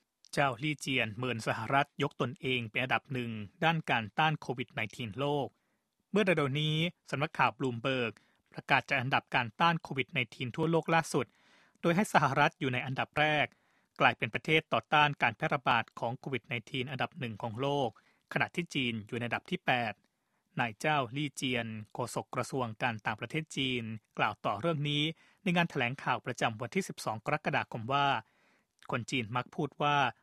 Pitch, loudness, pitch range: 140 Hz, -32 LUFS, 120-155 Hz